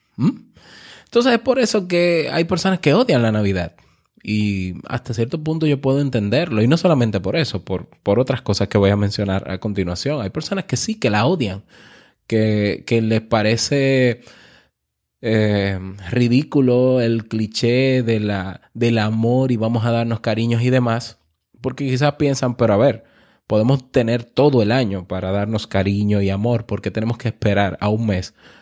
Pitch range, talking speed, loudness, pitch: 105-130 Hz, 175 wpm, -19 LUFS, 115 Hz